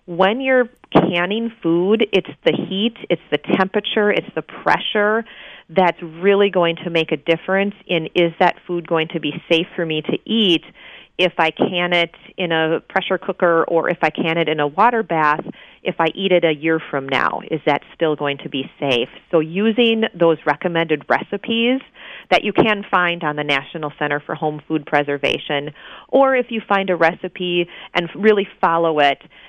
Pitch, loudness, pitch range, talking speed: 175 Hz, -18 LUFS, 160-200 Hz, 185 wpm